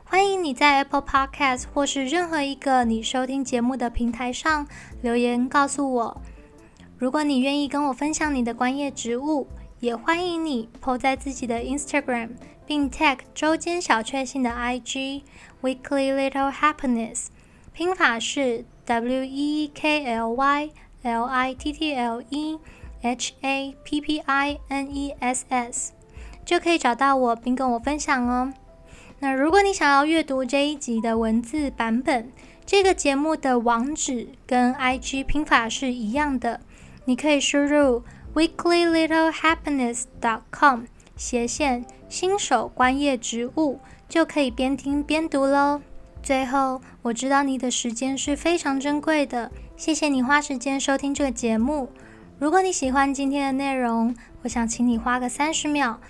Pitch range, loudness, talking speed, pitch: 250-295 Hz, -23 LUFS, 280 characters per minute, 275 Hz